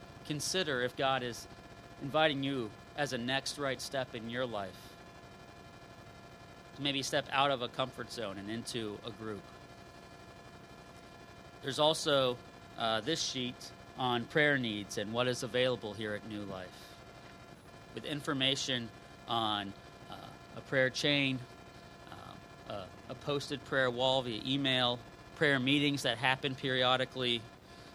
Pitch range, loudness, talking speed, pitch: 115-140 Hz, -33 LUFS, 135 wpm, 125 Hz